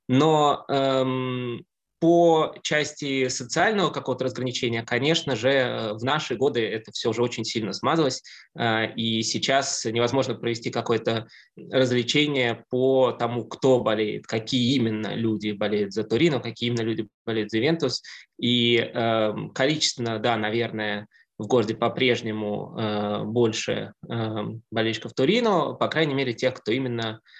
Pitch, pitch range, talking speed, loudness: 120 Hz, 110-130 Hz, 130 wpm, -24 LUFS